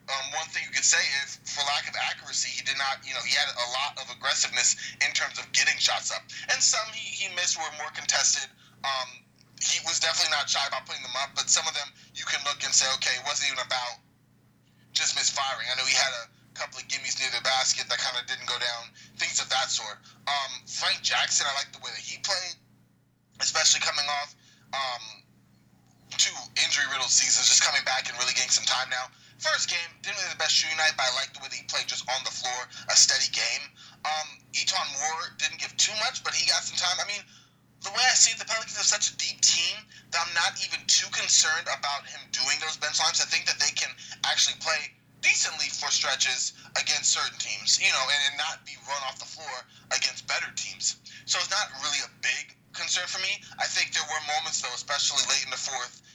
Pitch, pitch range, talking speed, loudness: 135 Hz, 125-145 Hz, 230 wpm, -25 LUFS